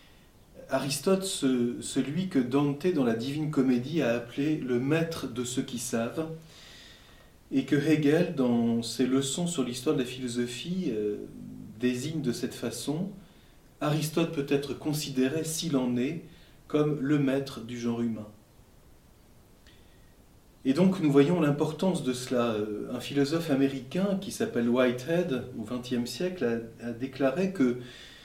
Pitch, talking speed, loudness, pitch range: 135 Hz, 140 wpm, -29 LUFS, 120-155 Hz